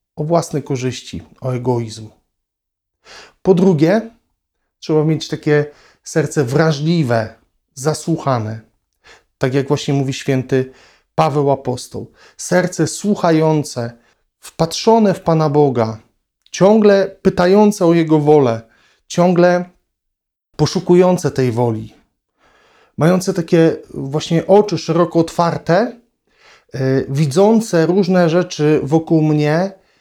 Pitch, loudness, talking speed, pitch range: 155 Hz, -15 LUFS, 95 wpm, 130-175 Hz